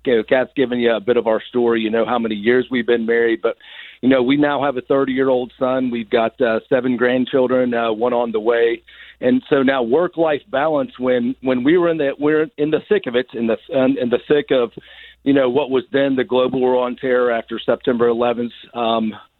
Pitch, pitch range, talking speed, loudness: 125 Hz, 120-135 Hz, 230 wpm, -18 LUFS